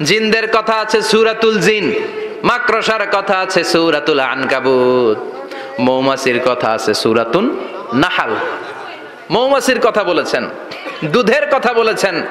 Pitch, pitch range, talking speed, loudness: 215 Hz, 130-225 Hz, 100 wpm, -14 LUFS